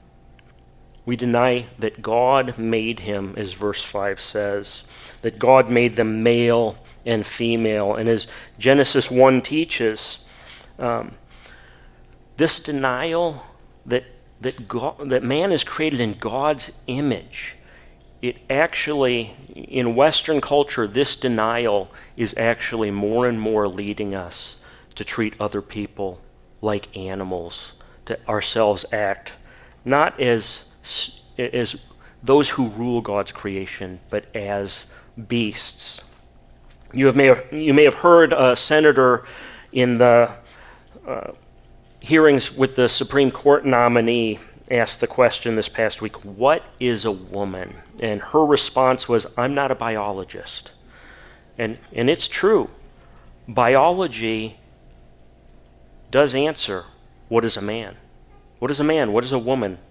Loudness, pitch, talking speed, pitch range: -20 LUFS, 115 Hz, 125 wpm, 100-130 Hz